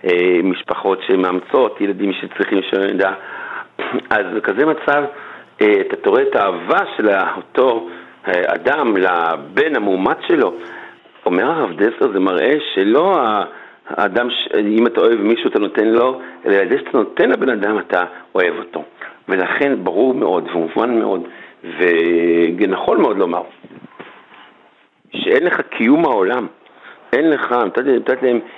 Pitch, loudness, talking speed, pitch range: 105 Hz, -16 LUFS, 130 wpm, 90-130 Hz